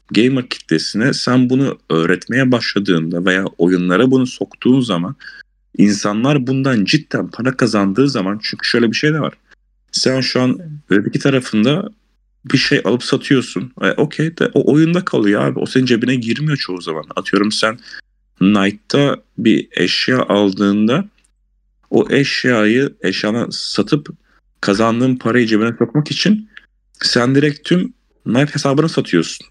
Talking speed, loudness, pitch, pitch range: 135 wpm, -15 LUFS, 125 Hz, 105-145 Hz